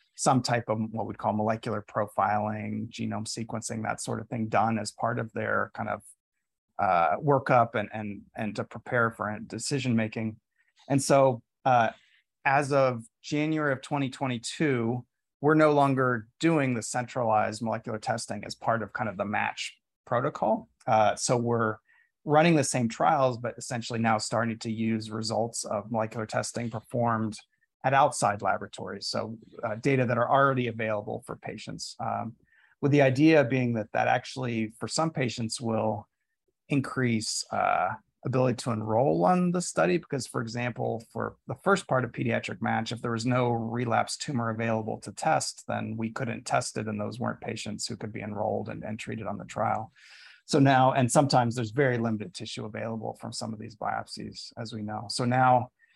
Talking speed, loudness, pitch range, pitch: 175 wpm, -28 LUFS, 110-130 Hz, 115 Hz